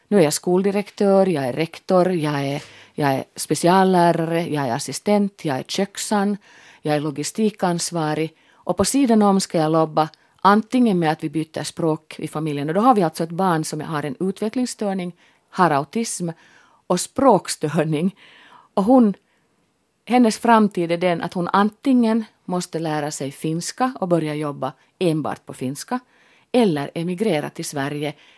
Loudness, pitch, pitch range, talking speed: -21 LUFS, 175 Hz, 155-205 Hz, 155 wpm